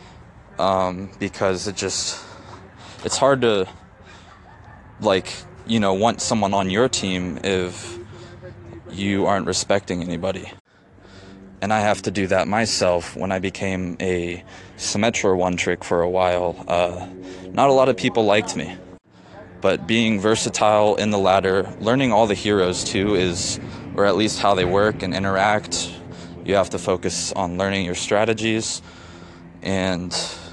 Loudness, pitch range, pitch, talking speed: -21 LUFS, 90-105 Hz, 95 Hz, 140 wpm